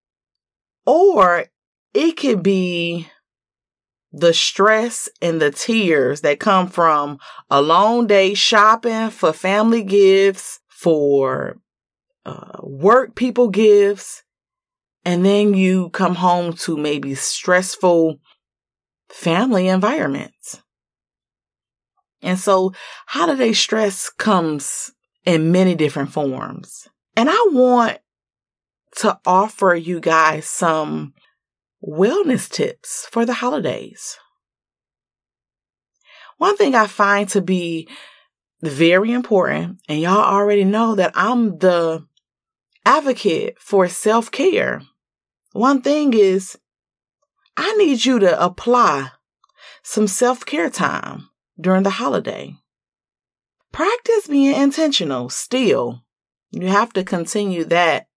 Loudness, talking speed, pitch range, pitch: -17 LUFS, 100 wpm, 170-240 Hz, 195 Hz